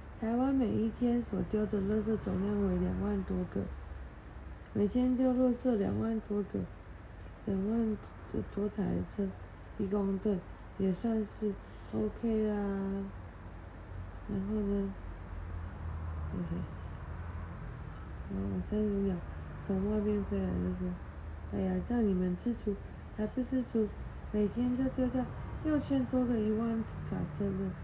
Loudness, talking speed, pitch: -35 LUFS, 165 characters per minute, 195 Hz